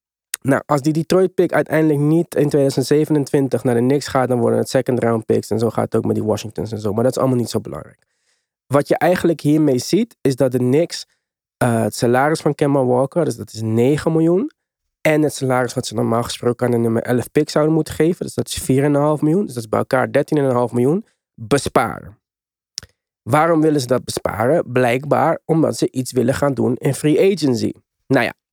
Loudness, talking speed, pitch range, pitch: -18 LUFS, 210 wpm, 120-150 Hz, 135 Hz